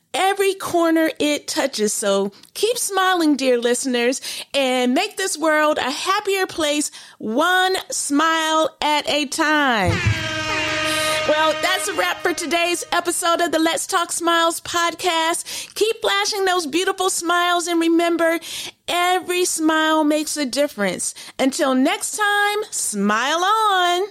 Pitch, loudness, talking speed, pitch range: 330 Hz, -19 LUFS, 125 wpm, 290-365 Hz